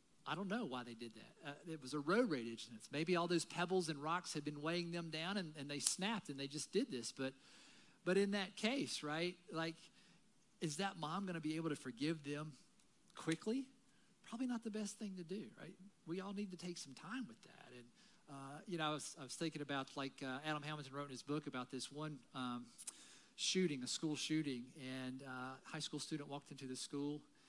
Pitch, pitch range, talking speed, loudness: 155 Hz, 140-195 Hz, 225 wpm, -44 LUFS